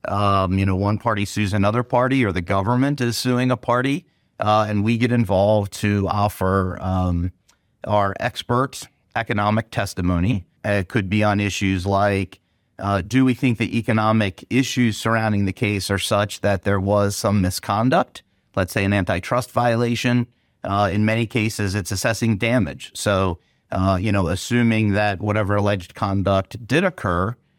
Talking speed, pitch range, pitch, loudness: 160 wpm, 100-120 Hz, 105 Hz, -21 LUFS